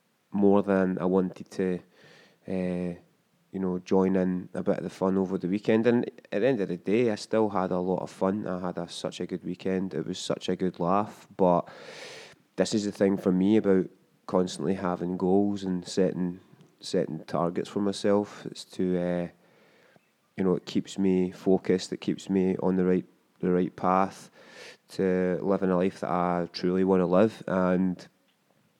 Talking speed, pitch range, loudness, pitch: 190 wpm, 90-95 Hz, -28 LUFS, 95 Hz